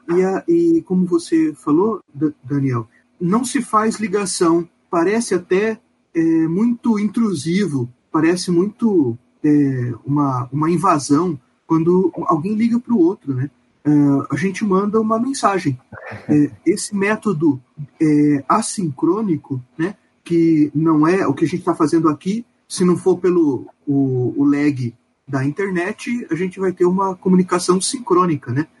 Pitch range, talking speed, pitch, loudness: 145-210 Hz, 140 wpm, 175 Hz, -18 LUFS